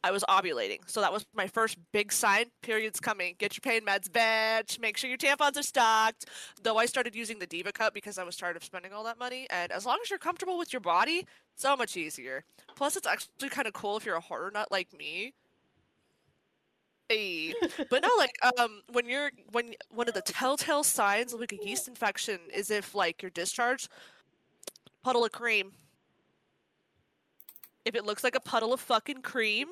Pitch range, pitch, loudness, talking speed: 205-265 Hz, 230 Hz, -30 LUFS, 200 wpm